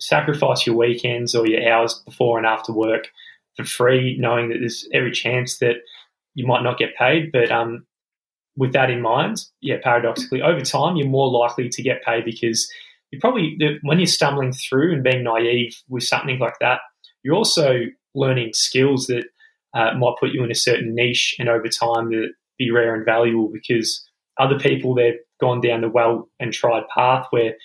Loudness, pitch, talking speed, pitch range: -19 LUFS, 120 Hz, 185 wpm, 115-135 Hz